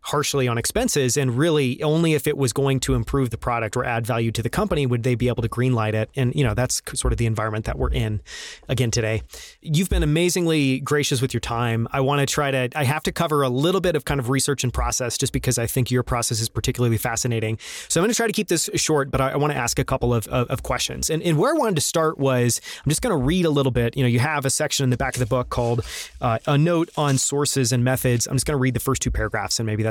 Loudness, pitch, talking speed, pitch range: -22 LUFS, 130 Hz, 285 wpm, 120-145 Hz